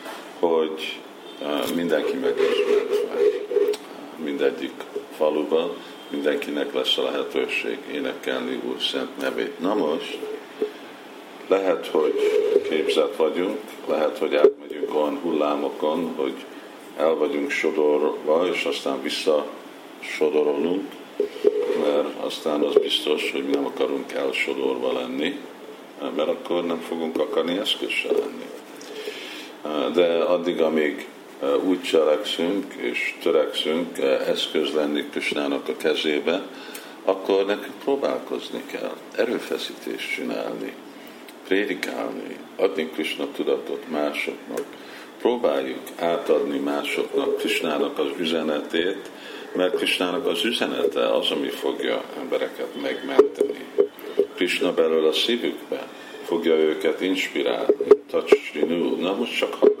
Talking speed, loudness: 100 wpm, -24 LUFS